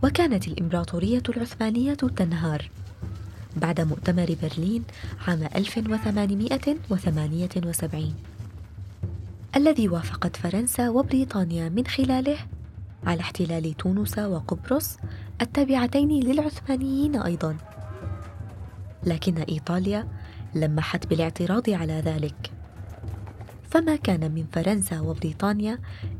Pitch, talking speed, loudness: 165 Hz, 75 wpm, -26 LUFS